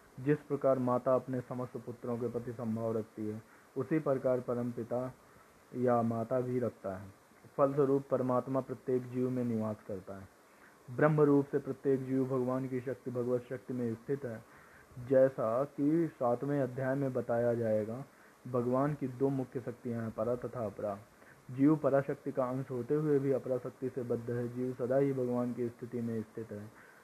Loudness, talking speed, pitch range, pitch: -34 LUFS, 155 wpm, 120-135 Hz, 125 Hz